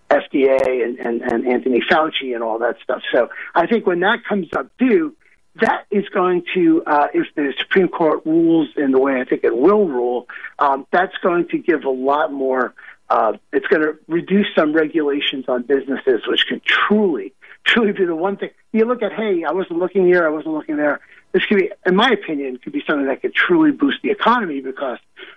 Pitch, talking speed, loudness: 185 Hz, 210 wpm, -18 LUFS